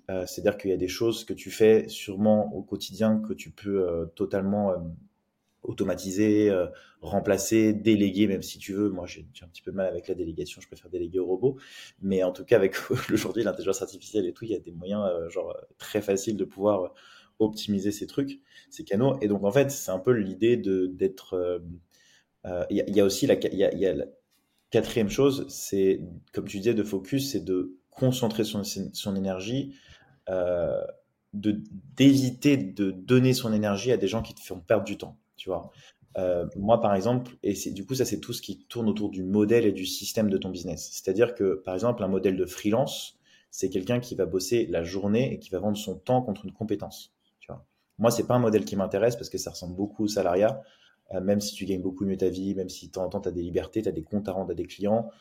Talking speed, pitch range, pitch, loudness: 235 wpm, 95-110 Hz, 100 Hz, -27 LUFS